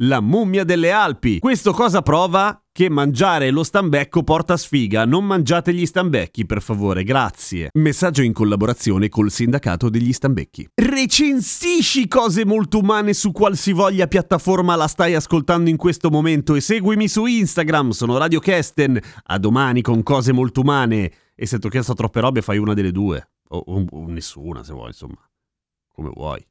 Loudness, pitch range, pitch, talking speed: -17 LUFS, 115-190 Hz, 150 Hz, 160 wpm